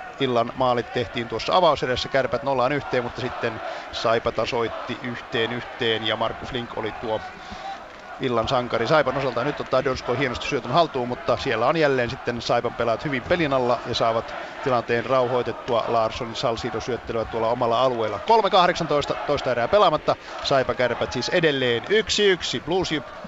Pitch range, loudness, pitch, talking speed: 115-145 Hz, -23 LUFS, 125 Hz, 150 wpm